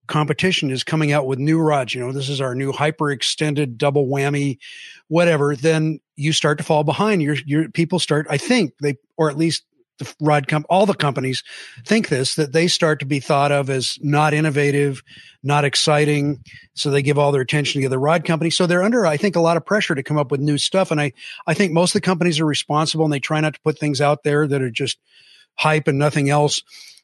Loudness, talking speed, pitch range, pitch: -19 LUFS, 235 wpm, 145-160 Hz, 150 Hz